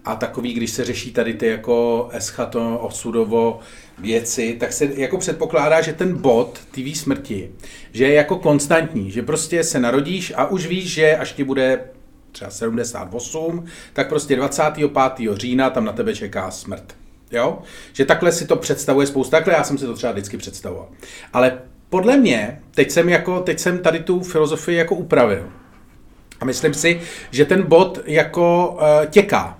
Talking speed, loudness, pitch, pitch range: 170 wpm, -18 LUFS, 140 Hz, 120-165 Hz